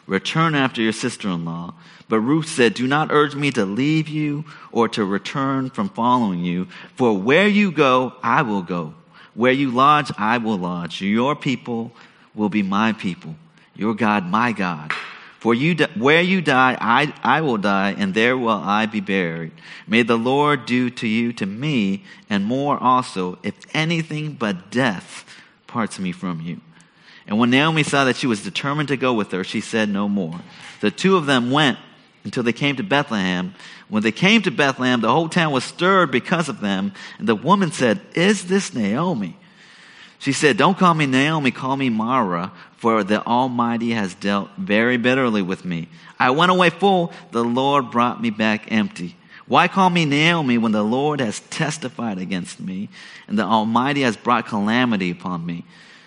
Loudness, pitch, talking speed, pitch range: -19 LUFS, 125 Hz, 185 wpm, 105-150 Hz